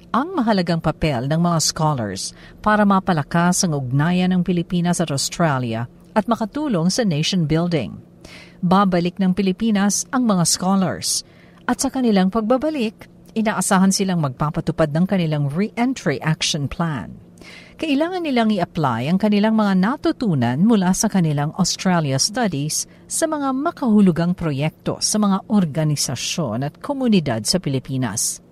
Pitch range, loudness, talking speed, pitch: 155-215 Hz, -19 LUFS, 125 wpm, 180 Hz